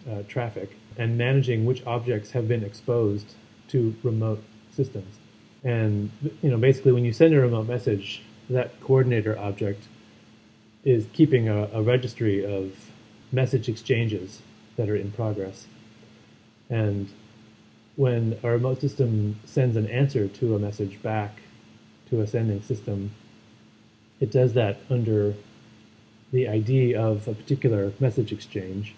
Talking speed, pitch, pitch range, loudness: 135 wpm, 110 Hz, 105-125 Hz, -25 LUFS